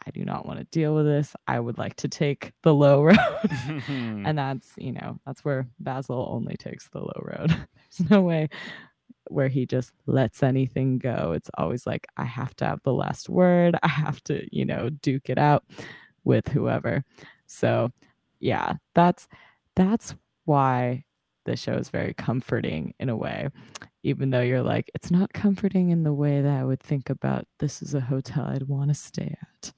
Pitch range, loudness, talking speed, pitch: 130-165 Hz, -25 LUFS, 190 wpm, 145 Hz